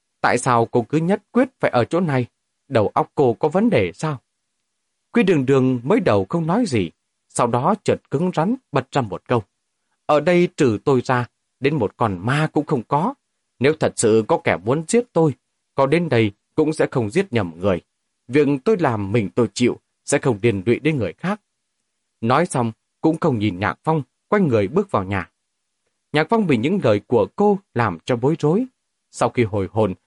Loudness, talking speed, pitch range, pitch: -20 LUFS, 205 wpm, 120-170 Hz, 135 Hz